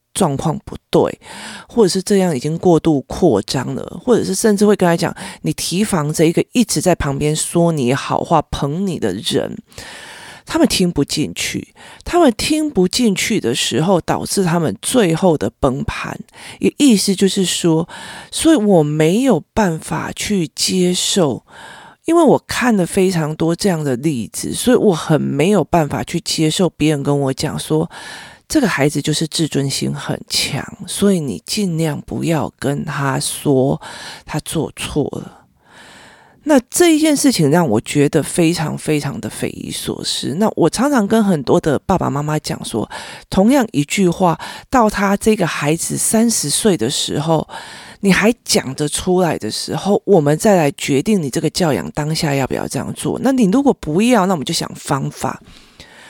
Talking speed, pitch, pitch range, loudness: 245 characters per minute, 170 Hz, 150-205 Hz, -16 LUFS